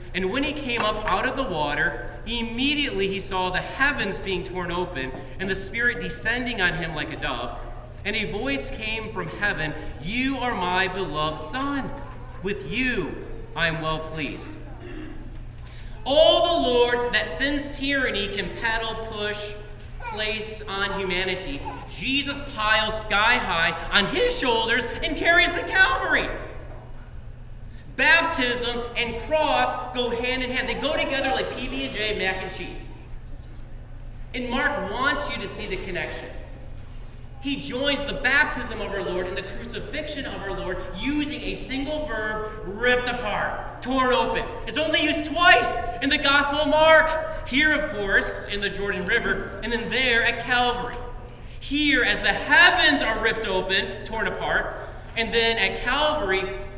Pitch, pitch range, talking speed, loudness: 225 Hz, 185-275 Hz, 150 wpm, -23 LUFS